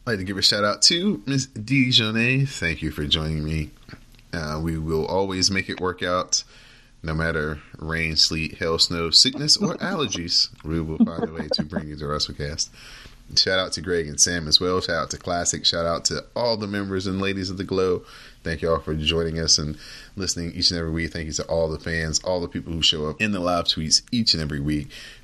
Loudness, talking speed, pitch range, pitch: -22 LUFS, 235 wpm, 80-100 Hz, 85 Hz